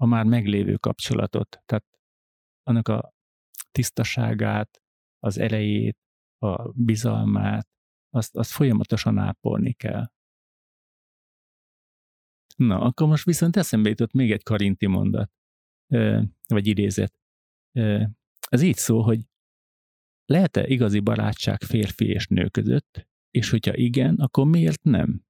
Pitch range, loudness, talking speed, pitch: 105-120 Hz, -23 LUFS, 110 wpm, 110 Hz